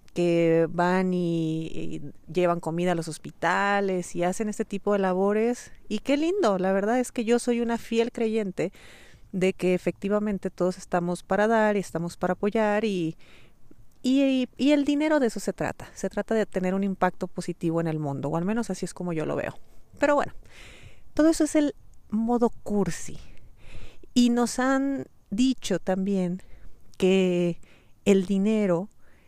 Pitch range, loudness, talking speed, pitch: 180-230 Hz, -26 LUFS, 170 wpm, 195 Hz